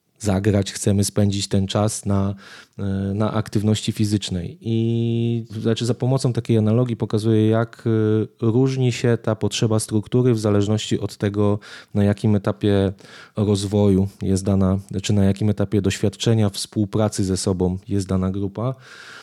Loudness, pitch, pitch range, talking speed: -21 LUFS, 105 Hz, 100-115 Hz, 135 wpm